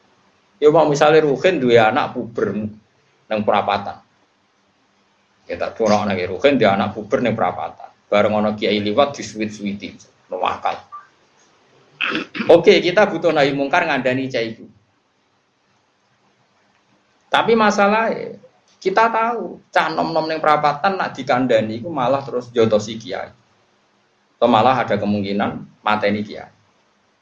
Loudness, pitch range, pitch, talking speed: -18 LUFS, 105-165 Hz, 130 Hz, 125 wpm